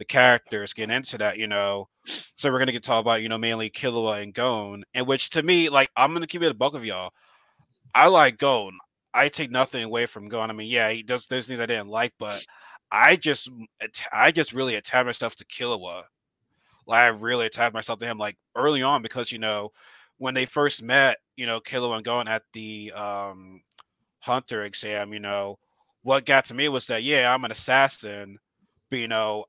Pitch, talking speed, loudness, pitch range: 115 Hz, 210 wpm, -23 LUFS, 105-130 Hz